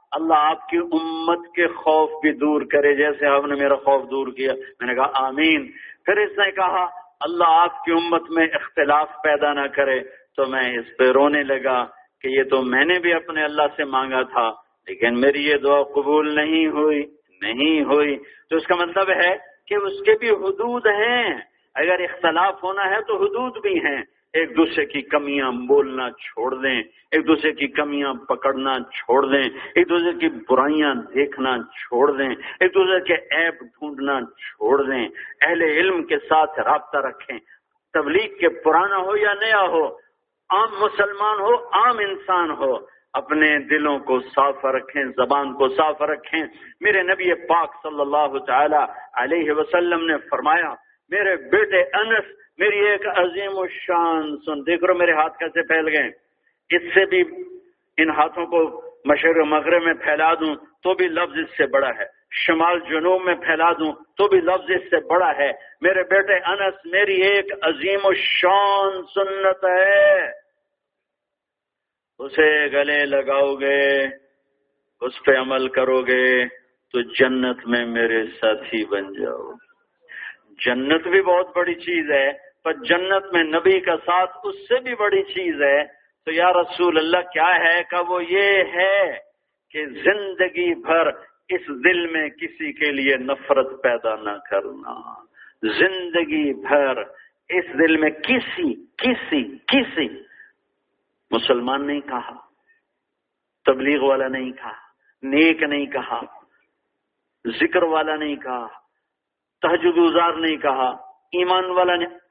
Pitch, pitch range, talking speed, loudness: 165 Hz, 140-195 Hz, 150 wpm, -20 LUFS